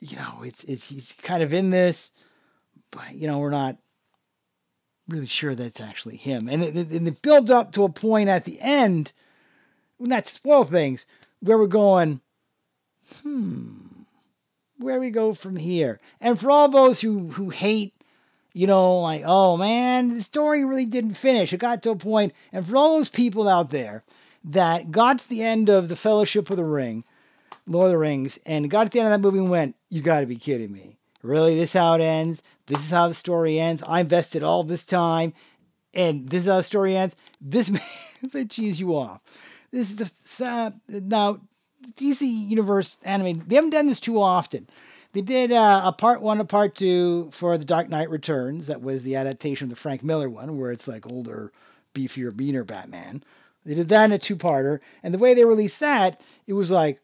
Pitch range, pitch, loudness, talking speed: 155-220 Hz, 185 Hz, -22 LUFS, 200 wpm